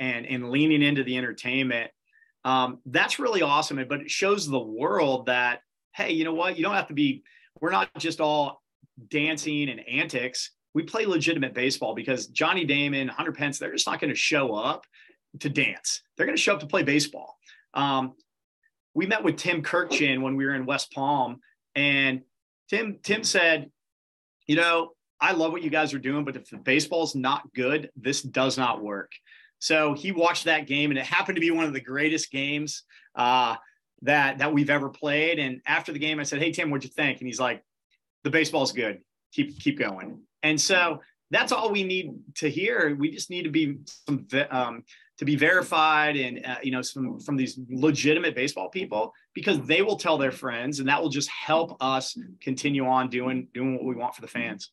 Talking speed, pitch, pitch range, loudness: 200 wpm, 145 Hz, 130-165 Hz, -25 LUFS